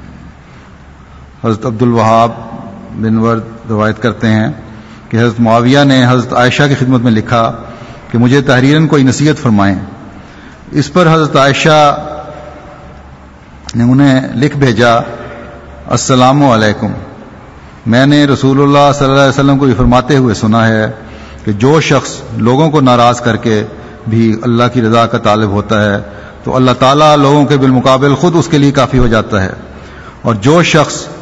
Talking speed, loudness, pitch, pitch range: 155 wpm, -9 LUFS, 120 Hz, 110-140 Hz